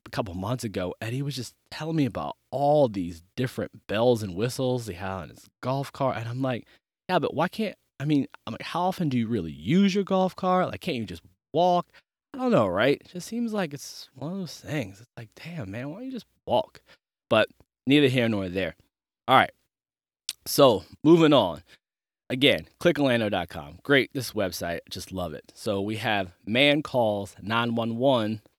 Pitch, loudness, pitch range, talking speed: 130 Hz, -26 LUFS, 110-165 Hz, 195 wpm